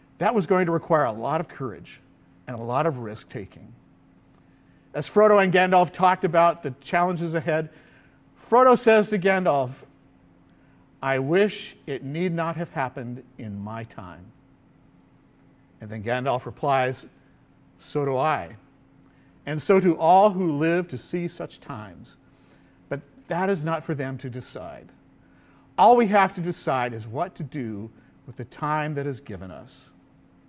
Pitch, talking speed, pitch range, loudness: 150 Hz, 155 wpm, 130-175 Hz, -23 LUFS